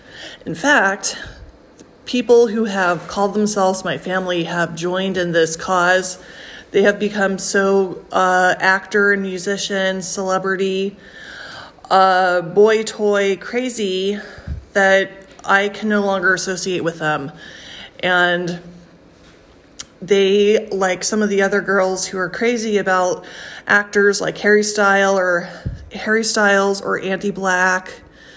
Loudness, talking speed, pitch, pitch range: -17 LUFS, 115 wpm, 195 Hz, 185-205 Hz